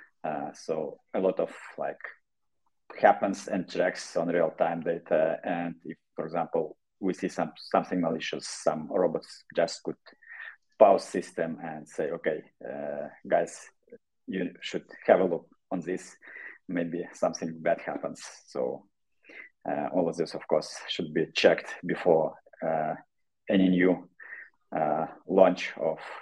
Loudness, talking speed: -29 LUFS, 135 wpm